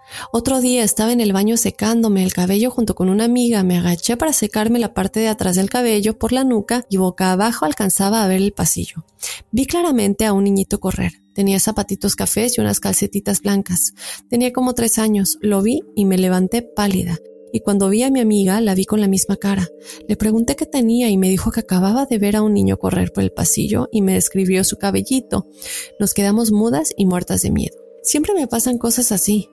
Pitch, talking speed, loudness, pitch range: 210 Hz, 210 wpm, -16 LUFS, 190-235 Hz